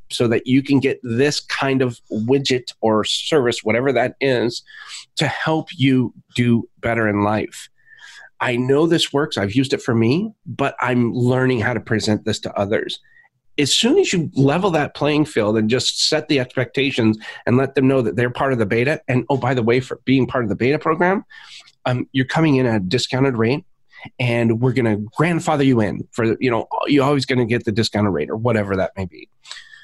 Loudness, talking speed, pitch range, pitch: -19 LUFS, 205 wpm, 115-145 Hz, 130 Hz